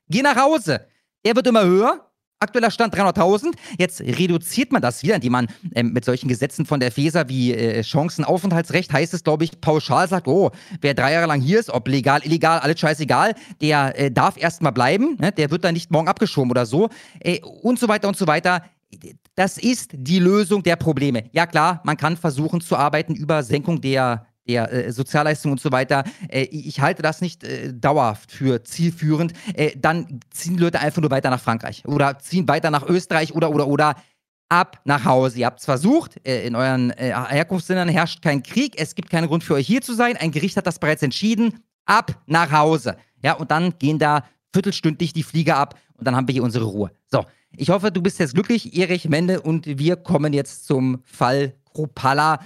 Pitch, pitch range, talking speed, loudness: 155 Hz, 140-180 Hz, 205 wpm, -20 LUFS